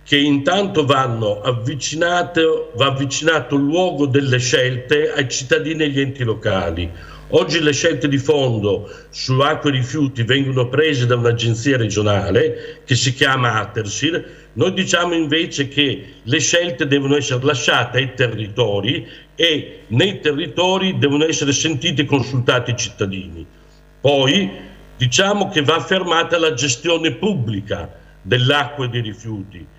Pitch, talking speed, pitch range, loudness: 140 Hz, 135 wpm, 125-155 Hz, -17 LUFS